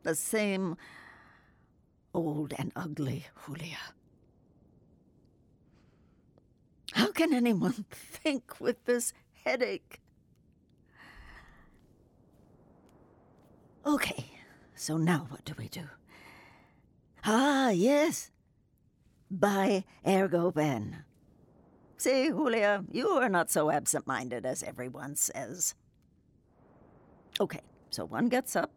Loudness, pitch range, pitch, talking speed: -31 LUFS, 140-235 Hz, 175 Hz, 85 wpm